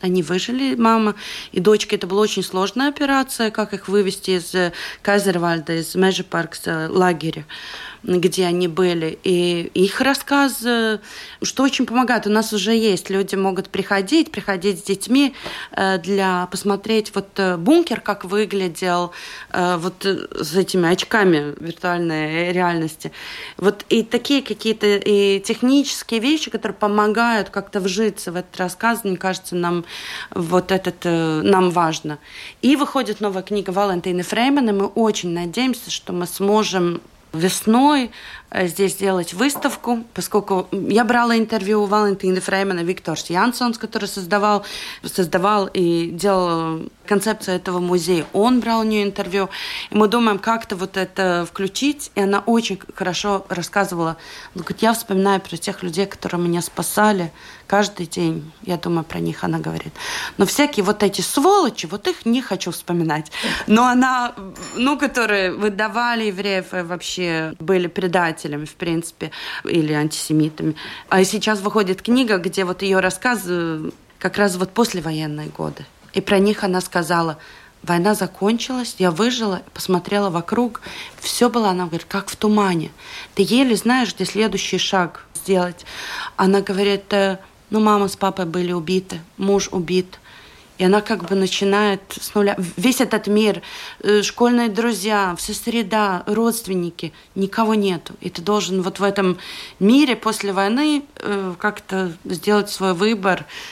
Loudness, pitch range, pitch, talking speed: -19 LUFS, 180-215 Hz, 195 Hz, 140 wpm